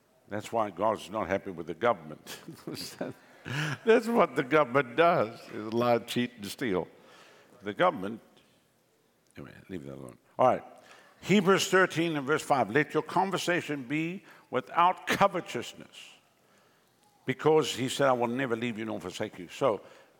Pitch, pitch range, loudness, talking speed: 140 Hz, 110-170 Hz, -29 LUFS, 145 wpm